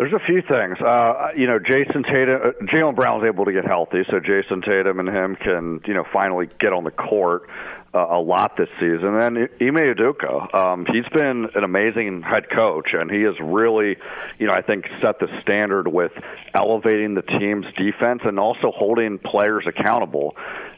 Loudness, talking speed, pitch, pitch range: -20 LUFS, 190 wpm, 110 Hz, 95-125 Hz